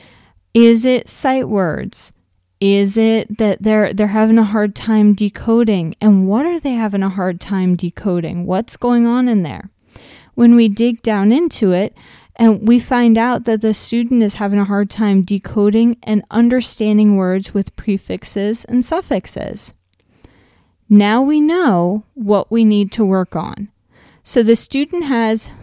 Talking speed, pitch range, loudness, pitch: 155 wpm, 200-235 Hz, -15 LUFS, 215 Hz